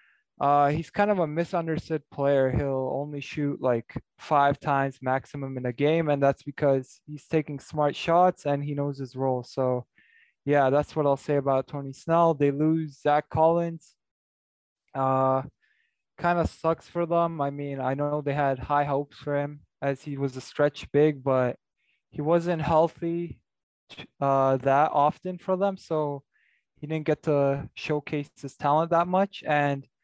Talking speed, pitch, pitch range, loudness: 170 wpm, 145 Hz, 135-160 Hz, -26 LUFS